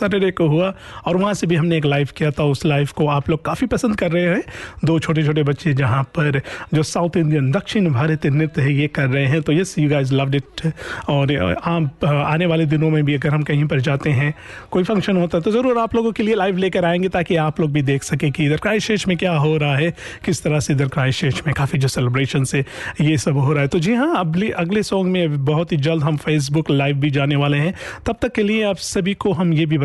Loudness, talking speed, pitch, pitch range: -18 LUFS, 255 wpm, 155 Hz, 145-180 Hz